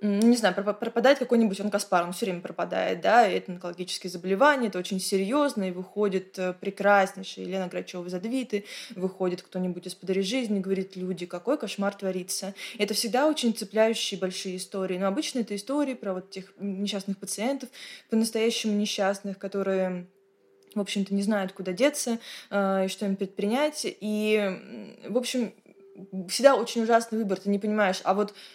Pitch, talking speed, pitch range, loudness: 200 Hz, 160 wpm, 190-225 Hz, -27 LUFS